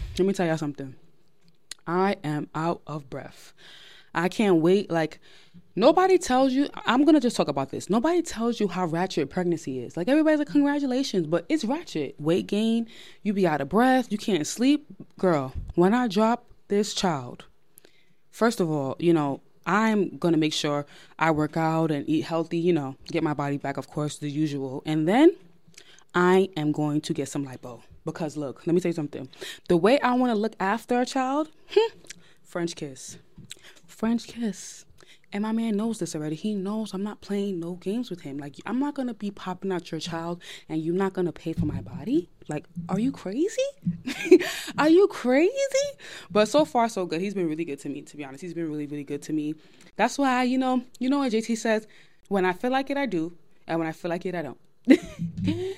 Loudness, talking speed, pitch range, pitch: -25 LUFS, 210 wpm, 160-235 Hz, 180 Hz